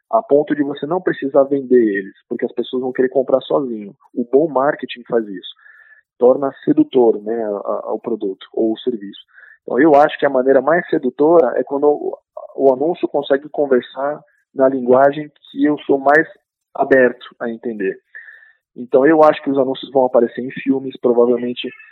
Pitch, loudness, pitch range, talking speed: 135 Hz, -16 LUFS, 125-150 Hz, 180 wpm